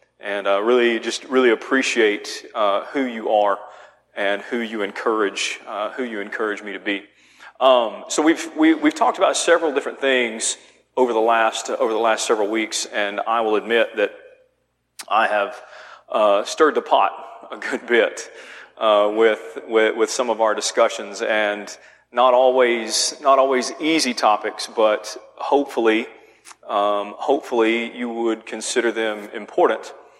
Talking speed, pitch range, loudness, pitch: 155 wpm, 105-130 Hz, -20 LUFS, 115 Hz